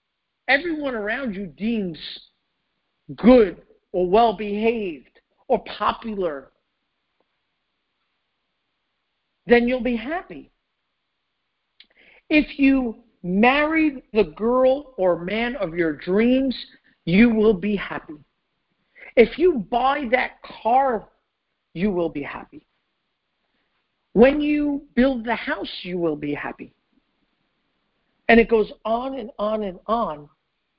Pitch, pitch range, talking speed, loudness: 230 Hz, 200-265 Hz, 105 wpm, -21 LUFS